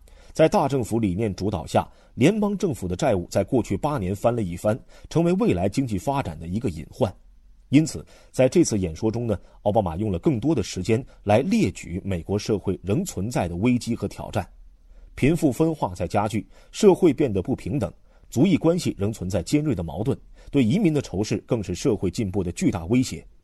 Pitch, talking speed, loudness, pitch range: 105 Hz, 295 characters per minute, -24 LUFS, 90-130 Hz